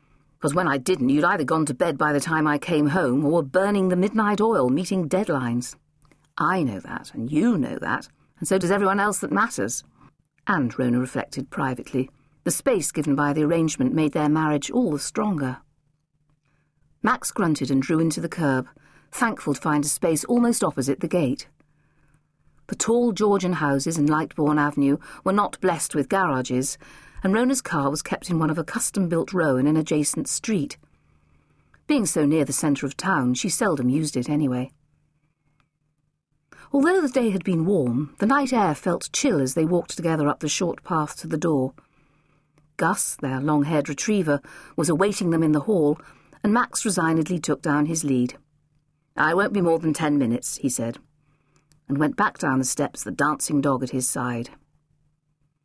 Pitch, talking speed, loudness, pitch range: 150 Hz, 185 wpm, -23 LUFS, 140-175 Hz